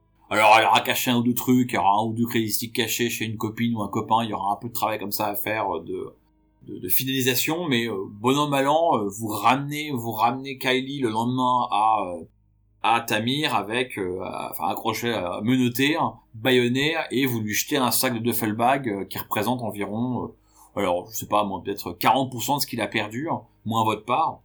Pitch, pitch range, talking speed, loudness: 115 Hz, 105-125 Hz, 205 wpm, -23 LUFS